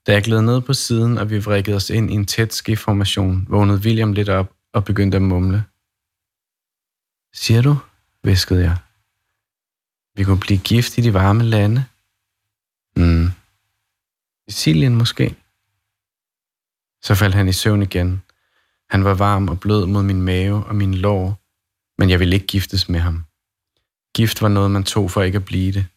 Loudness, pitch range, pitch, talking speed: -17 LUFS, 95-105 Hz, 100 Hz, 165 wpm